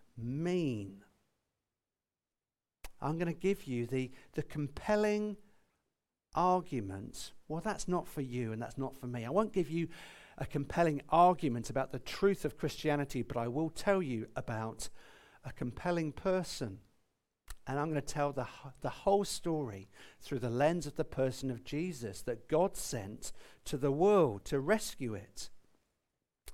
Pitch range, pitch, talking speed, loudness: 125-175 Hz, 145 Hz, 150 wpm, -35 LUFS